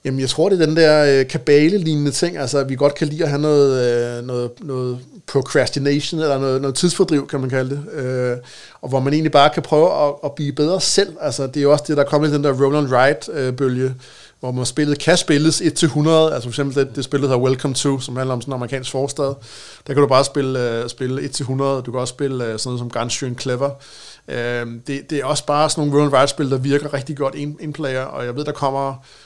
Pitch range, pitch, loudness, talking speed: 130-150 Hz, 140 Hz, -18 LUFS, 240 wpm